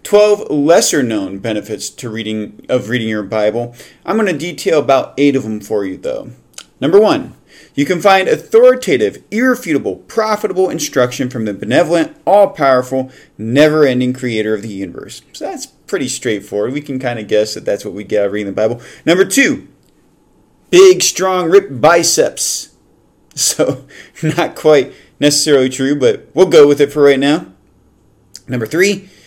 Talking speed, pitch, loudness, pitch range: 165 wpm, 140 Hz, -13 LUFS, 110-180 Hz